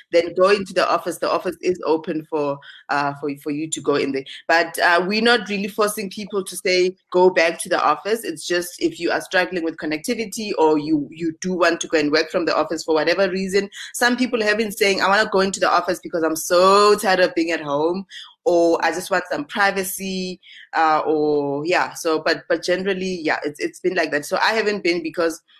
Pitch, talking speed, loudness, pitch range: 180 Hz, 230 wpm, -20 LUFS, 160-200 Hz